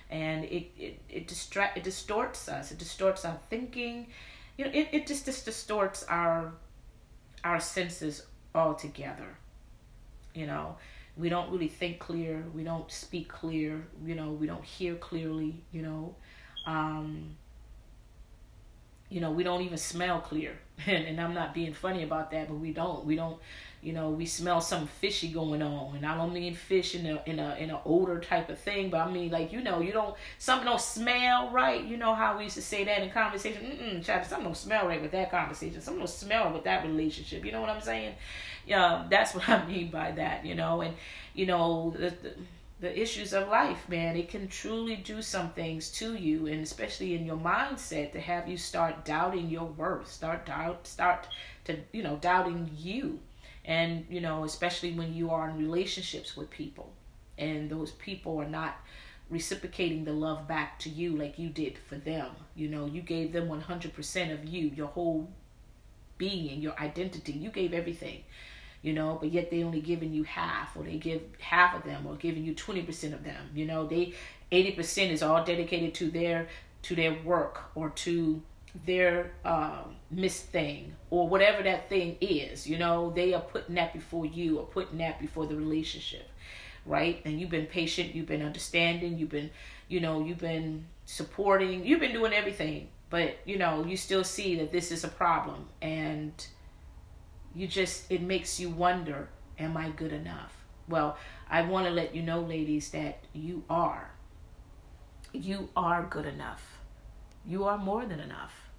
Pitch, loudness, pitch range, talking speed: 165 Hz, -32 LUFS, 155-180 Hz, 185 wpm